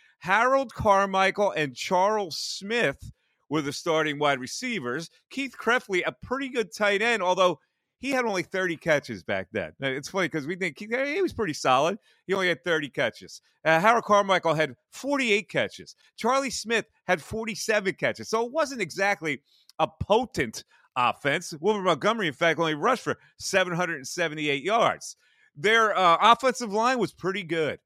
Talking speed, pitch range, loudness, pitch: 160 wpm, 160-225 Hz, -25 LUFS, 190 Hz